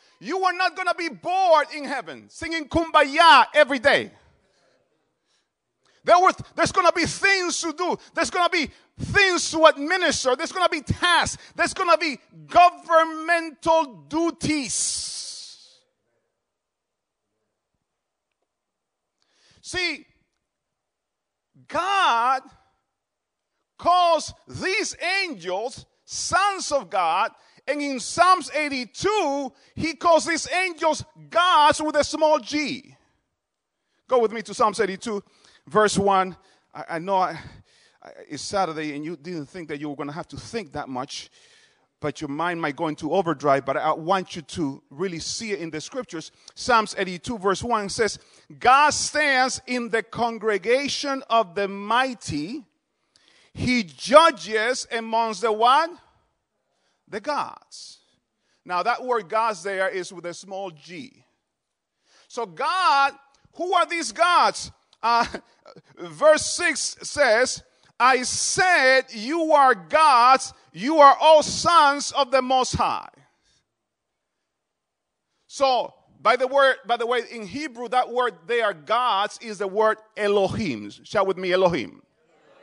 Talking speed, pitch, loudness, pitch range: 135 wpm, 255 Hz, -21 LUFS, 200-320 Hz